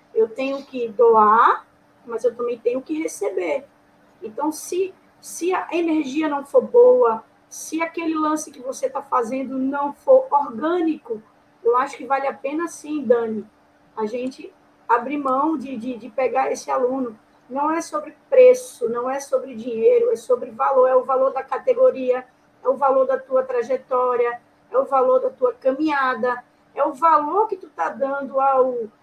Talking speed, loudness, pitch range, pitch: 170 wpm, -20 LUFS, 255-315 Hz, 270 Hz